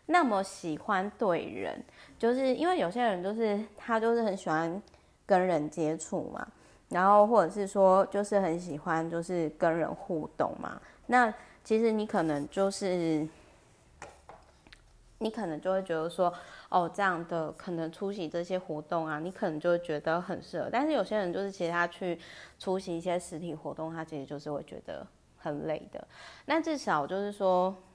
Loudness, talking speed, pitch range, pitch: -31 LUFS, 255 characters per minute, 165-205 Hz, 180 Hz